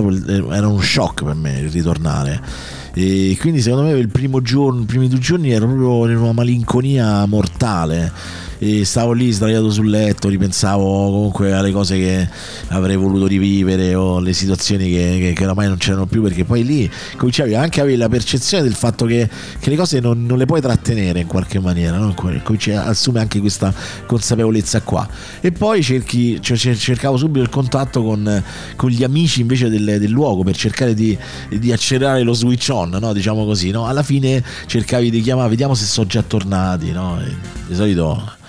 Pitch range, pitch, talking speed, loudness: 95-125 Hz, 110 Hz, 180 wpm, -16 LUFS